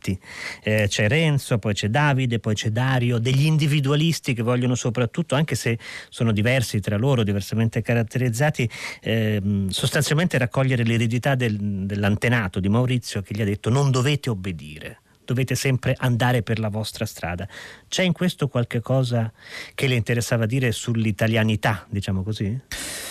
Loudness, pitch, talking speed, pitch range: -22 LUFS, 120 Hz, 145 wpm, 110-130 Hz